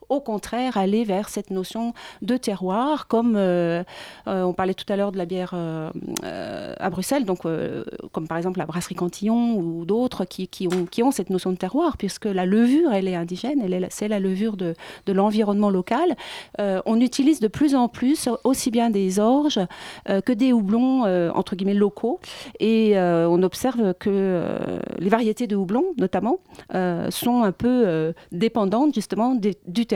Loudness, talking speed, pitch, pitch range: -23 LUFS, 195 wpm, 205 Hz, 185-240 Hz